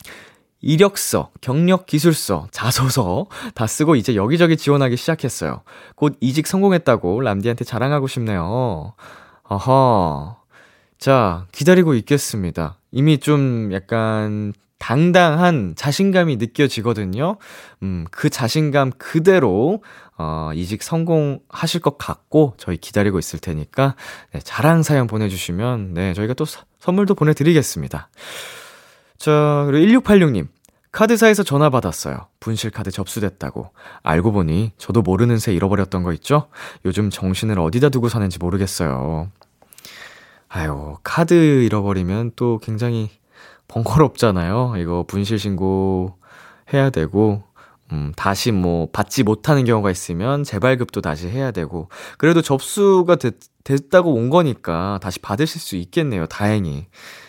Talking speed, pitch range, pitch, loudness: 290 characters per minute, 95-145 Hz, 115 Hz, -18 LUFS